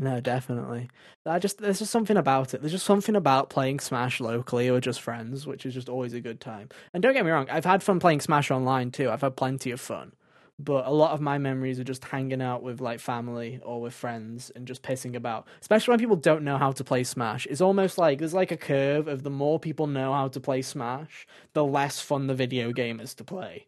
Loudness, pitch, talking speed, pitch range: -27 LUFS, 135 Hz, 245 wpm, 125-155 Hz